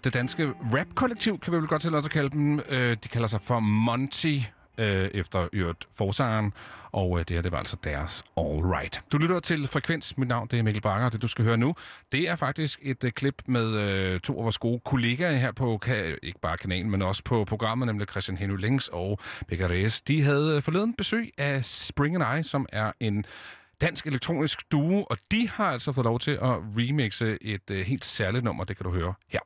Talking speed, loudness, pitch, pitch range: 210 wpm, -28 LUFS, 120 Hz, 100-145 Hz